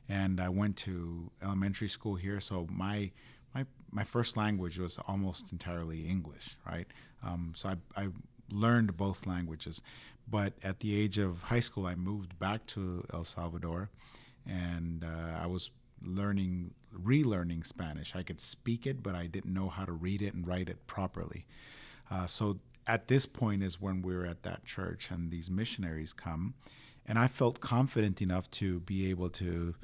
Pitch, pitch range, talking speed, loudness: 95 Hz, 90-105 Hz, 175 wpm, -36 LUFS